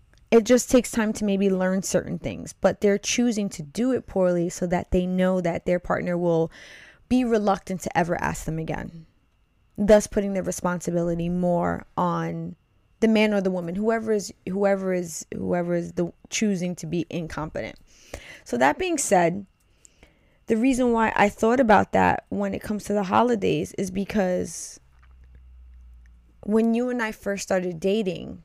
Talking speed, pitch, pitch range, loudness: 165 wpm, 185 Hz, 170-215 Hz, -24 LUFS